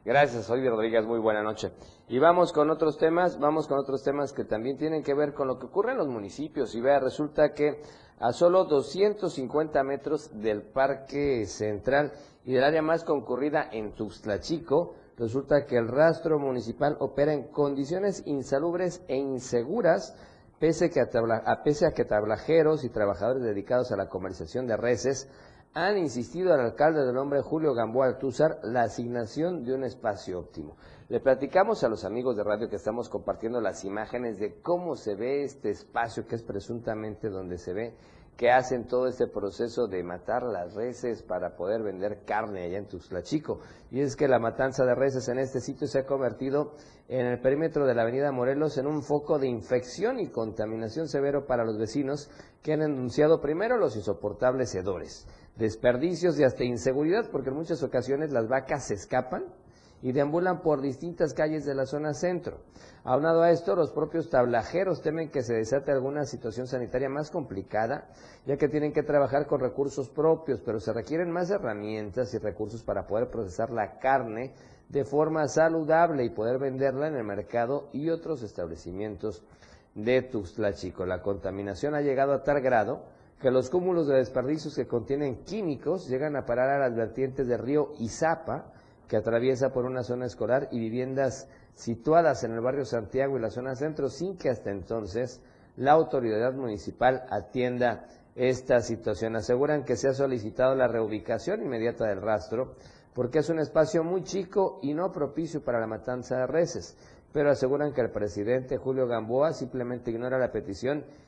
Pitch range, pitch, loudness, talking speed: 115-150 Hz, 130 Hz, -28 LUFS, 175 wpm